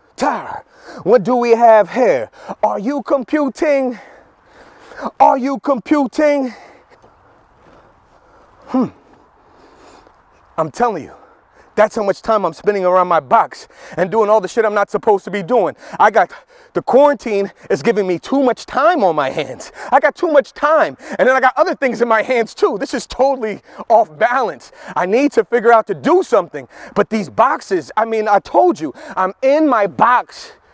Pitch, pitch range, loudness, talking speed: 245 Hz, 215-285 Hz, -15 LUFS, 170 wpm